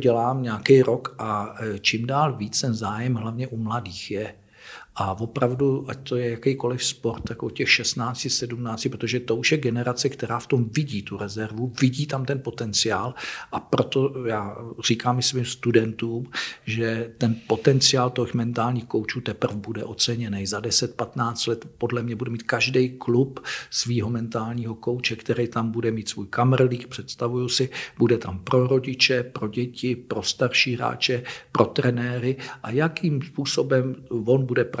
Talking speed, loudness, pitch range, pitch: 160 wpm, -24 LUFS, 115-130 Hz, 120 Hz